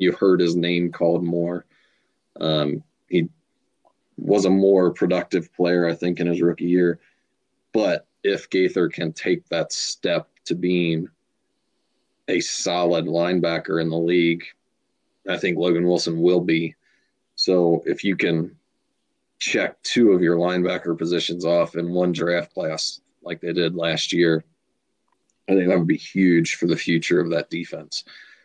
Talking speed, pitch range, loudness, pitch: 150 wpm, 85-90 Hz, -21 LUFS, 85 Hz